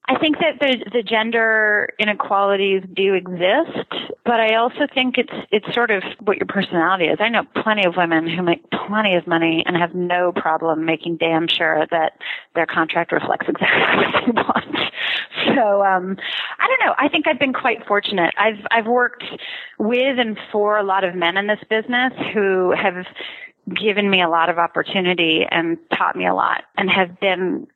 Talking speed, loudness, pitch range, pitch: 185 wpm, -18 LUFS, 175-230 Hz, 200 Hz